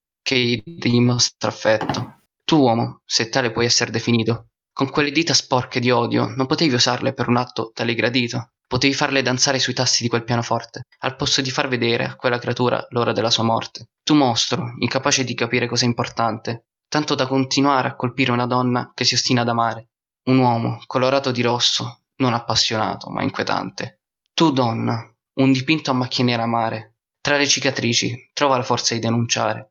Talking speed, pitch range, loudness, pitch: 180 wpm, 115-135 Hz, -19 LUFS, 125 Hz